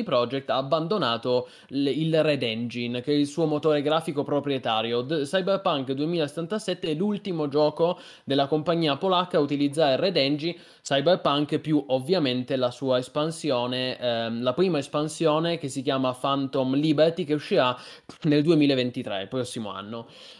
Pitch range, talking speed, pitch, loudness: 130-160 Hz, 140 wpm, 145 Hz, -25 LUFS